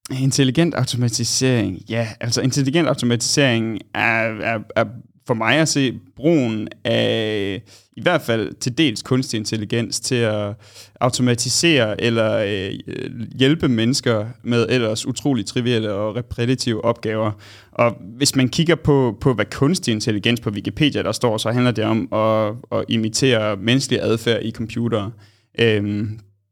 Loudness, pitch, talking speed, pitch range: -19 LUFS, 115 Hz, 140 wpm, 110-130 Hz